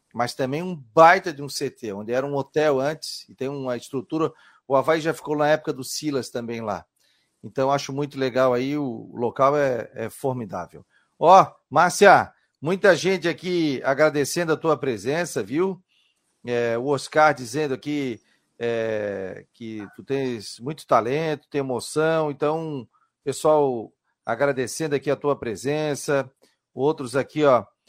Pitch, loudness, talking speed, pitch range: 140 Hz, -23 LUFS, 150 wpm, 125-155 Hz